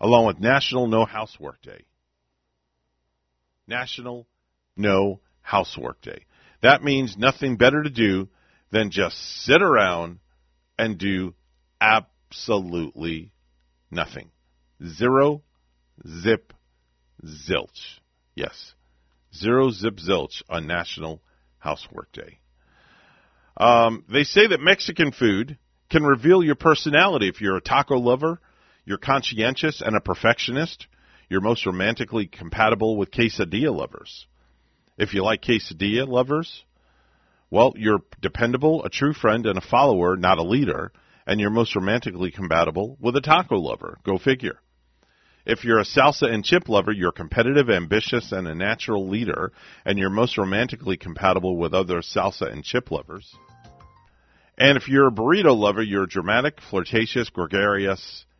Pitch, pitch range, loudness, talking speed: 100 Hz, 80-120 Hz, -21 LUFS, 130 wpm